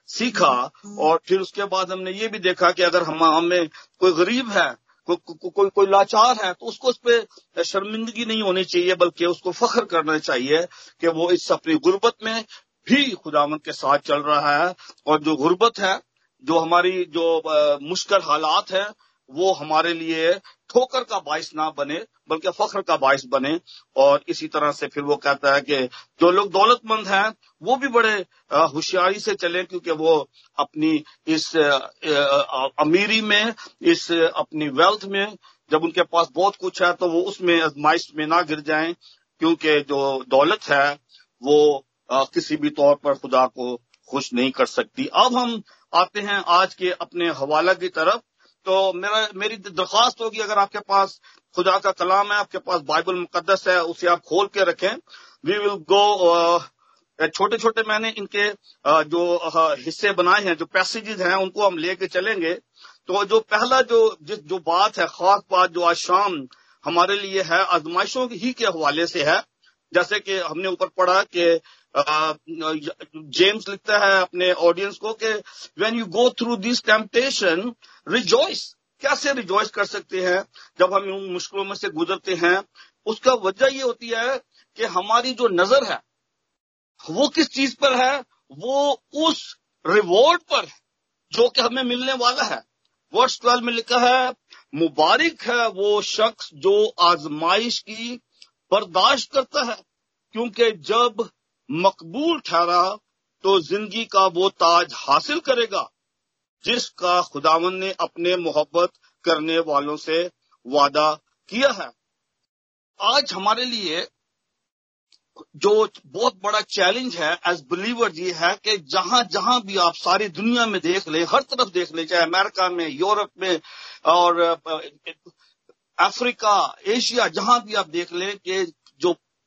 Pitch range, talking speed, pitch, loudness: 170-230 Hz, 160 wpm, 190 Hz, -20 LUFS